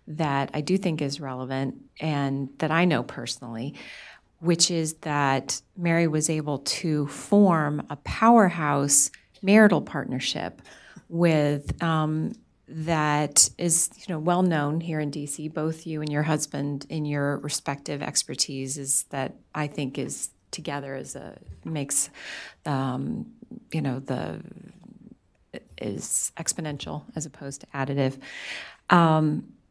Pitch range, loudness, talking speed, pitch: 140-170 Hz, -25 LUFS, 125 wpm, 150 Hz